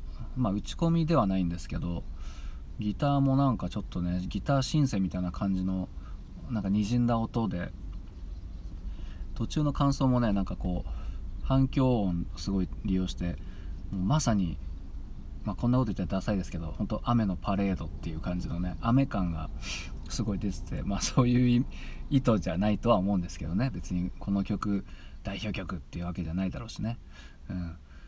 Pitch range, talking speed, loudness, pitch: 85-105 Hz, 355 characters per minute, -30 LUFS, 95 Hz